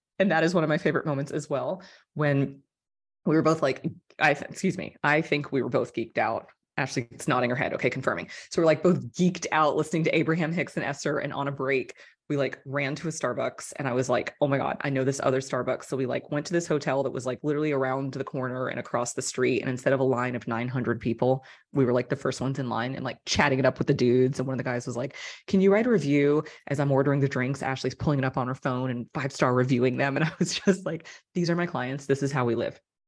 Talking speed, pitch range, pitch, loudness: 275 wpm, 130-155 Hz, 140 Hz, -27 LUFS